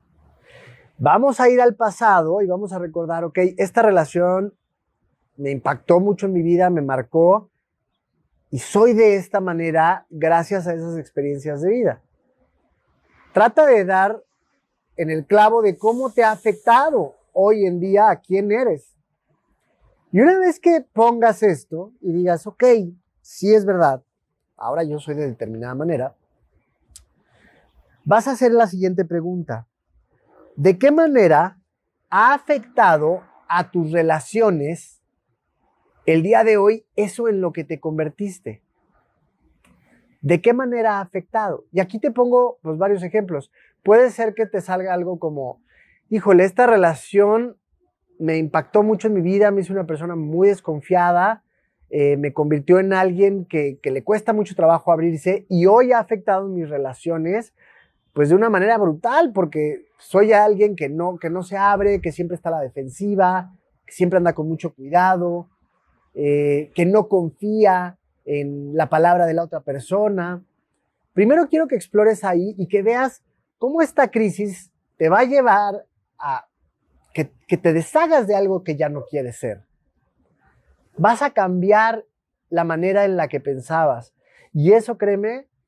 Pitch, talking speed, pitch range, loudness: 185 Hz, 155 wpm, 160-215 Hz, -18 LUFS